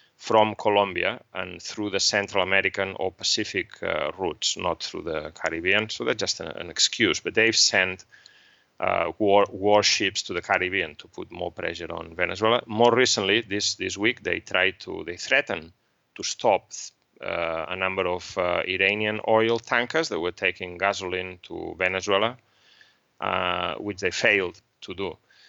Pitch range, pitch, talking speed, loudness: 95-110 Hz, 100 Hz, 160 wpm, -24 LUFS